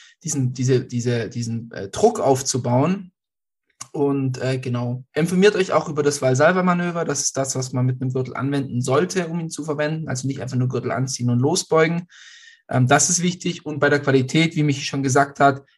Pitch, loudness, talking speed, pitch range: 140 Hz, -21 LUFS, 195 wpm, 130-160 Hz